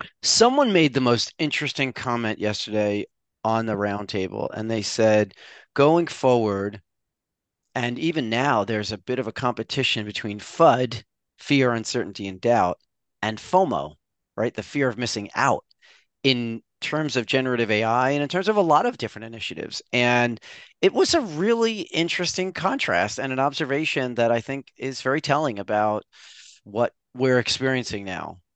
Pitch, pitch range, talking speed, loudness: 120 Hz, 110-140 Hz, 155 wpm, -23 LUFS